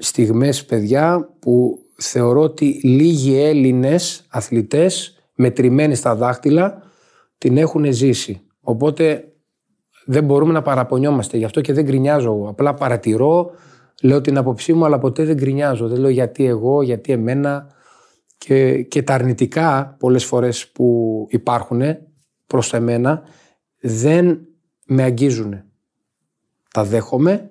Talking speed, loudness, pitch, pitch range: 120 wpm, -16 LUFS, 135 Hz, 120-150 Hz